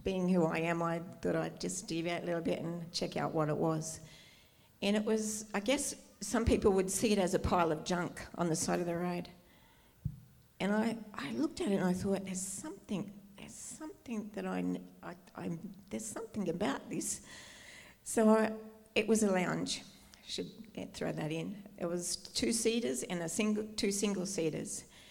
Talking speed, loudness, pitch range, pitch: 195 wpm, -35 LUFS, 170-215 Hz, 190 Hz